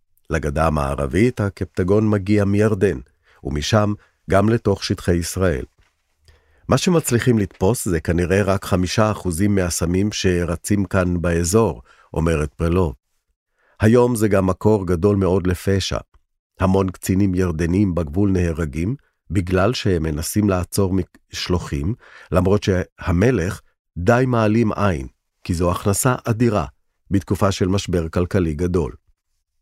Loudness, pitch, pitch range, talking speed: -20 LUFS, 95 Hz, 85-105 Hz, 110 wpm